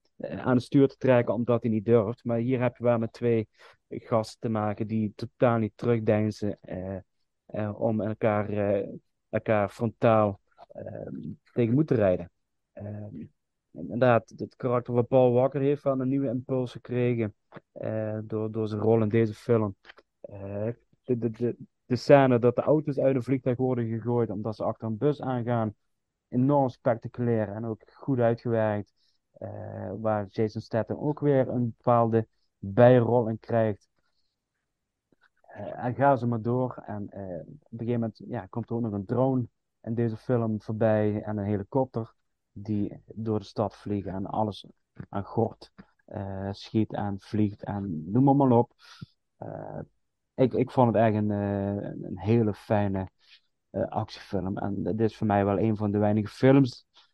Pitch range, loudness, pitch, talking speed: 105-125 Hz, -27 LUFS, 115 Hz, 170 wpm